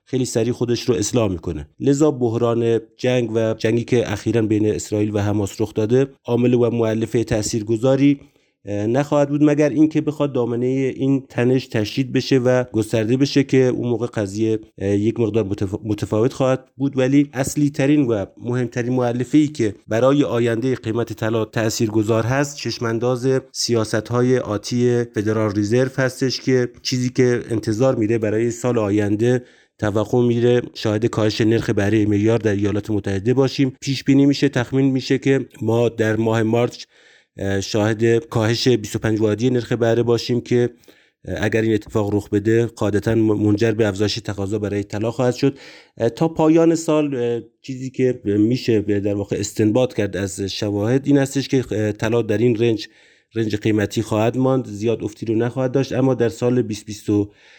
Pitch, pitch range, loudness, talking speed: 115 Hz, 110-130 Hz, -19 LUFS, 155 wpm